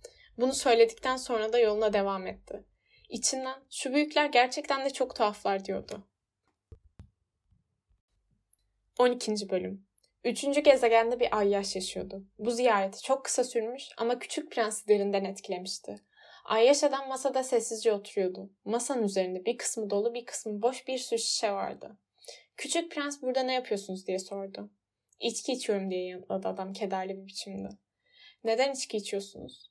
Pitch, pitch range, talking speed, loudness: 220 Hz, 190-260 Hz, 135 wpm, -30 LUFS